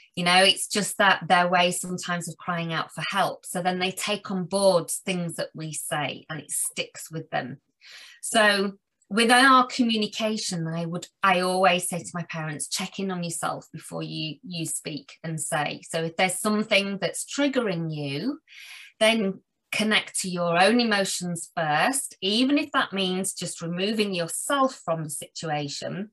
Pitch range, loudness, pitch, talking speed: 170-210 Hz, -24 LUFS, 185 Hz, 170 wpm